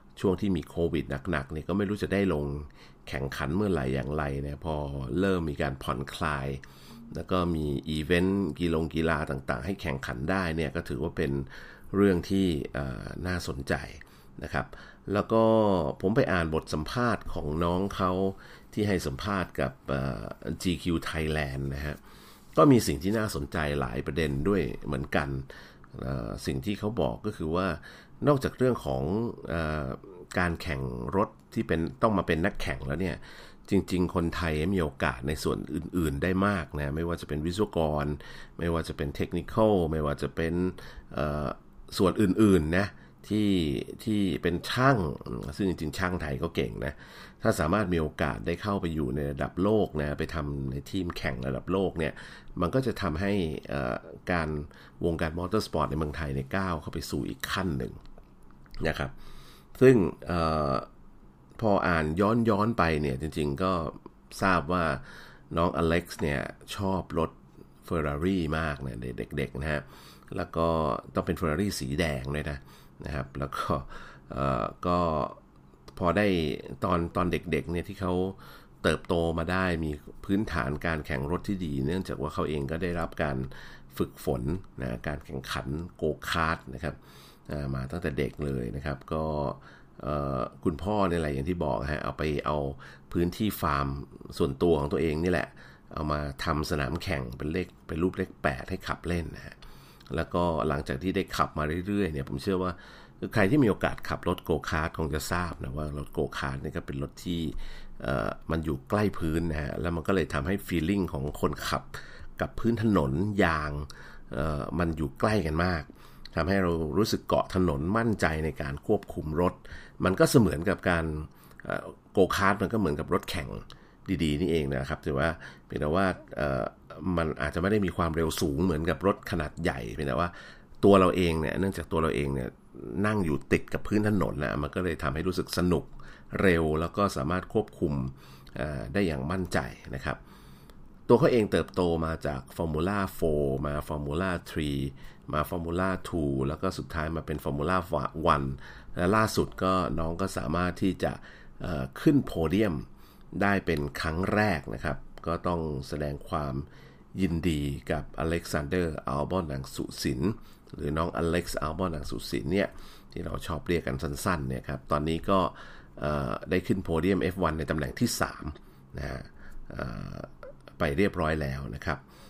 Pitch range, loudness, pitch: 70-90 Hz, -29 LUFS, 80 Hz